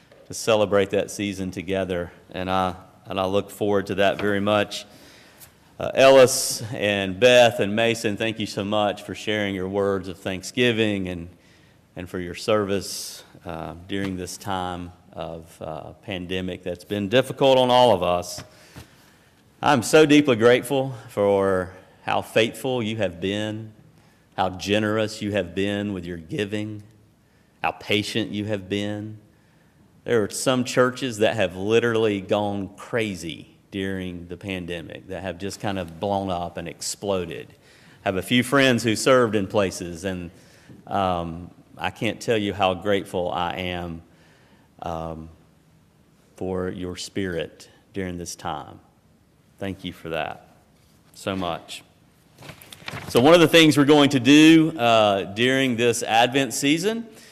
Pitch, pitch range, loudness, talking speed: 100 Hz, 95-115 Hz, -22 LUFS, 145 wpm